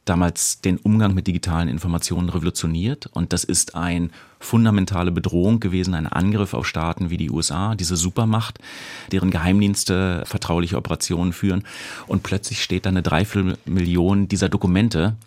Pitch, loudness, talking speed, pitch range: 90 Hz, -21 LUFS, 140 wpm, 85-100 Hz